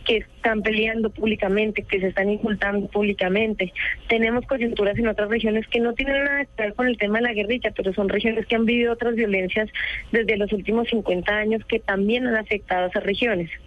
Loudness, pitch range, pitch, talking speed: -22 LUFS, 205-230 Hz, 220 Hz, 200 wpm